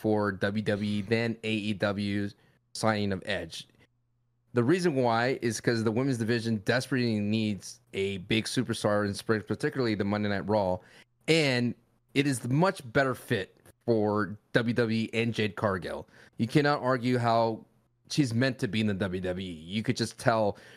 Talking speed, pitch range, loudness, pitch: 155 wpm, 105-120 Hz, -29 LUFS, 115 Hz